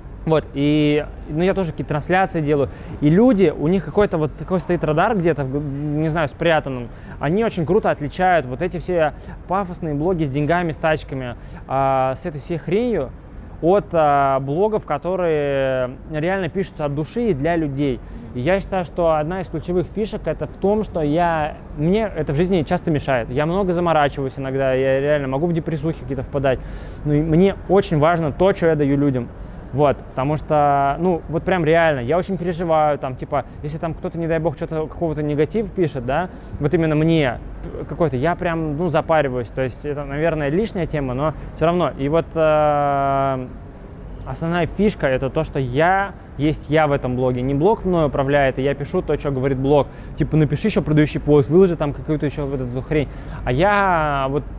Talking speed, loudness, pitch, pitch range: 185 wpm, -20 LUFS, 155 Hz, 140-175 Hz